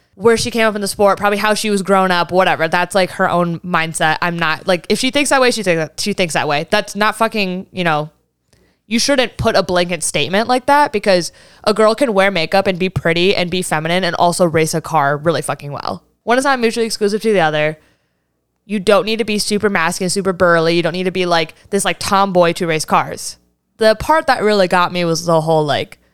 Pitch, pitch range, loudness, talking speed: 185 Hz, 165-210 Hz, -15 LUFS, 245 wpm